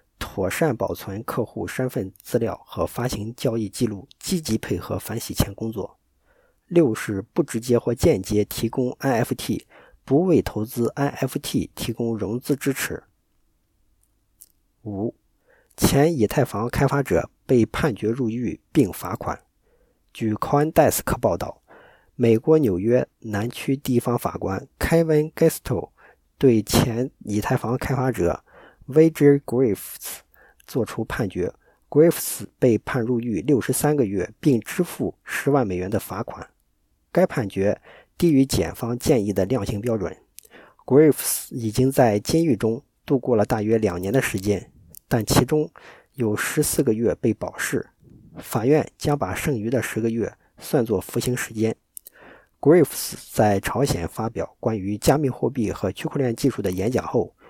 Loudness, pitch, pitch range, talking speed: -23 LUFS, 120 Hz, 105-135 Hz, 260 characters per minute